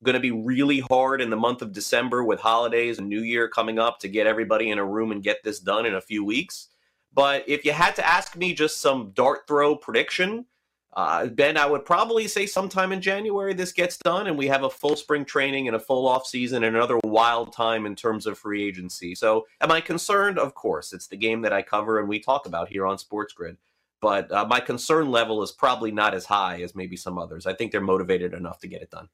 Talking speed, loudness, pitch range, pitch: 245 wpm, -24 LUFS, 105-150 Hz, 120 Hz